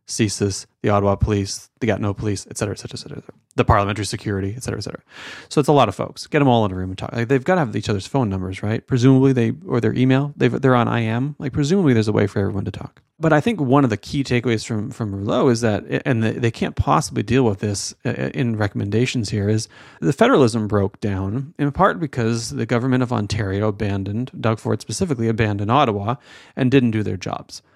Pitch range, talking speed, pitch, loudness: 105-130 Hz, 240 wpm, 115 Hz, -20 LUFS